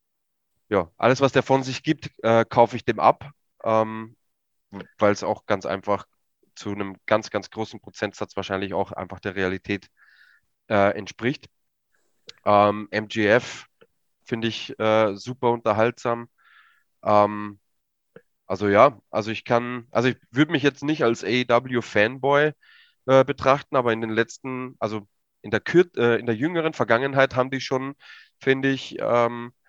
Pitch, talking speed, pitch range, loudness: 115 Hz, 150 wpm, 105-130 Hz, -23 LUFS